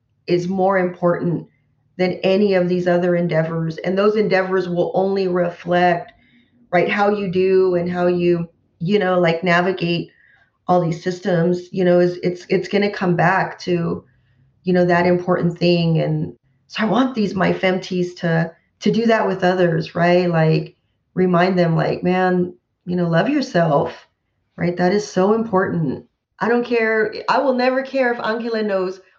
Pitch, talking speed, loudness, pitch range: 180 Hz, 170 wpm, -18 LUFS, 170-190 Hz